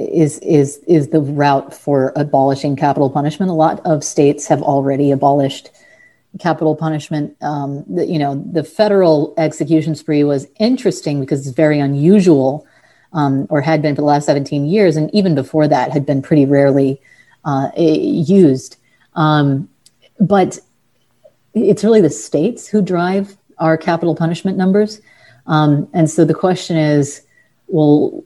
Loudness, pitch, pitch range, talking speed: -15 LUFS, 155 Hz, 145-175 Hz, 150 wpm